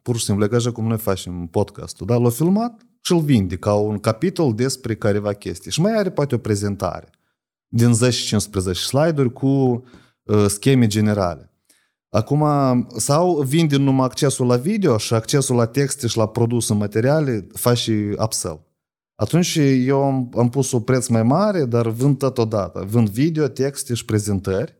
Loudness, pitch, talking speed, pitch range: -19 LUFS, 120 Hz, 170 wpm, 105-140 Hz